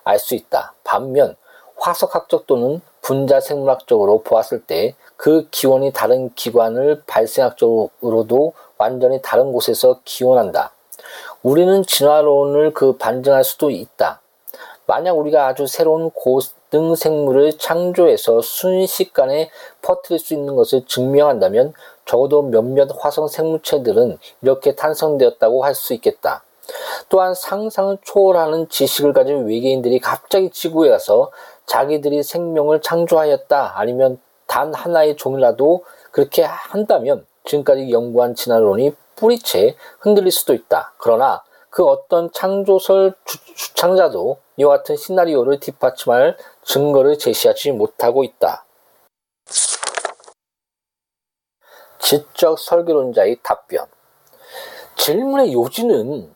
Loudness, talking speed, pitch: -16 LUFS, 275 characters per minute, 170 Hz